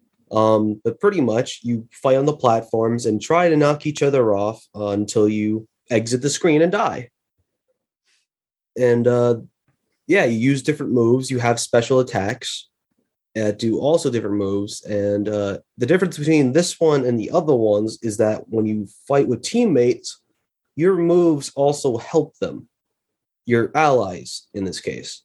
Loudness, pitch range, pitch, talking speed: -19 LUFS, 110-150 Hz, 120 Hz, 160 wpm